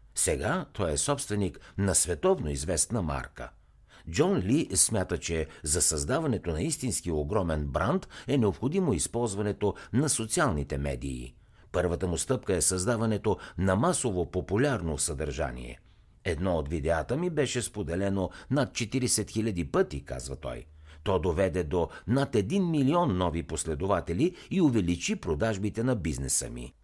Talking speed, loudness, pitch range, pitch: 130 wpm, -29 LUFS, 80-120 Hz, 95 Hz